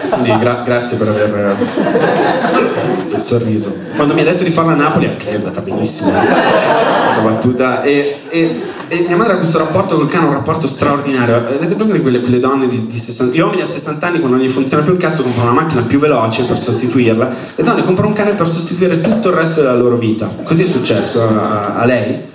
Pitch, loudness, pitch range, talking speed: 135 Hz, -13 LUFS, 120-165 Hz, 220 wpm